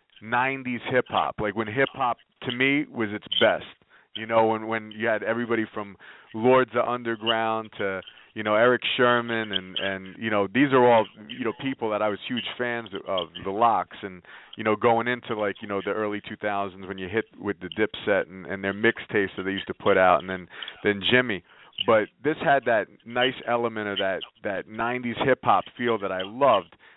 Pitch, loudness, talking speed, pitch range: 110 Hz, -25 LUFS, 210 wpm, 100-120 Hz